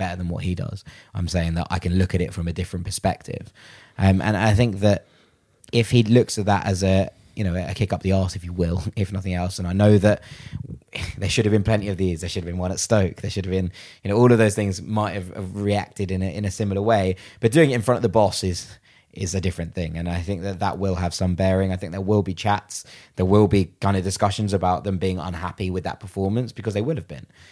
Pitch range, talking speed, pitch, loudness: 90-105 Hz, 275 wpm, 100 Hz, -22 LUFS